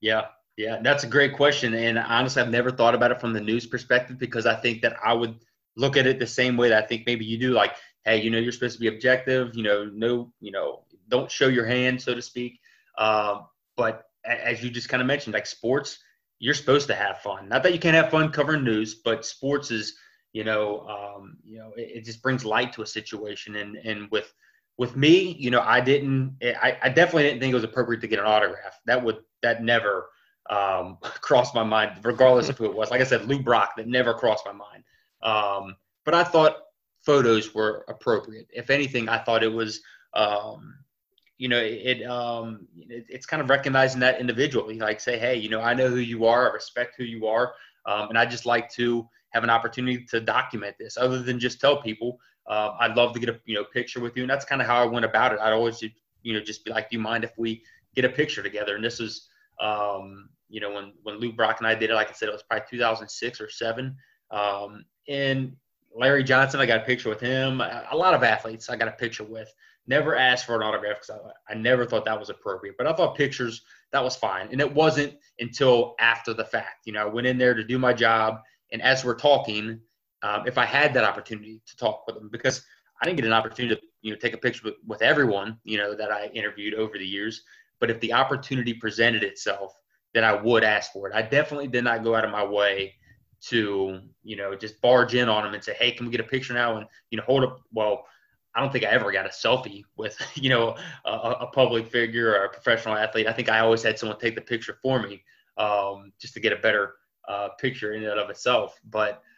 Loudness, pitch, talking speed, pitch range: -24 LUFS, 115 Hz, 240 wpm, 110-125 Hz